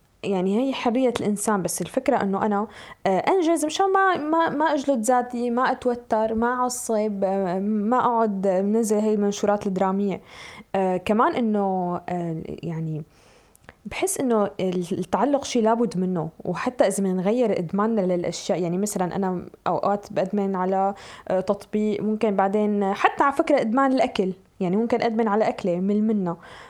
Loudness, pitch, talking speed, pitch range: -23 LUFS, 210 Hz, 135 wpm, 190-240 Hz